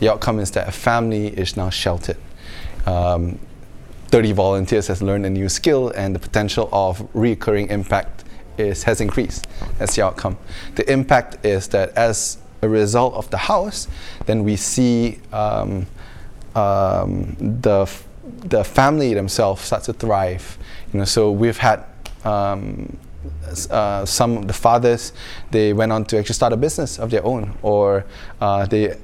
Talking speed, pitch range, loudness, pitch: 160 wpm, 95-115 Hz, -19 LUFS, 105 Hz